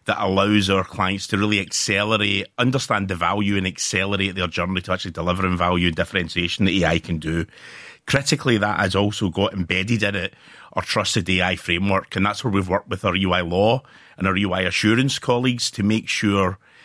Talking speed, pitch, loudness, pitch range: 190 wpm, 95 Hz, -21 LUFS, 90-105 Hz